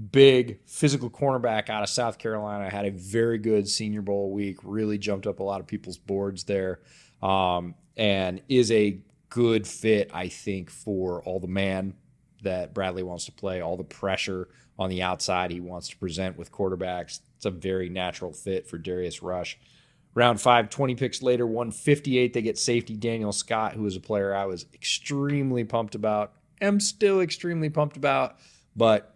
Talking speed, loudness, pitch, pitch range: 175 wpm, -27 LUFS, 105 Hz, 95-120 Hz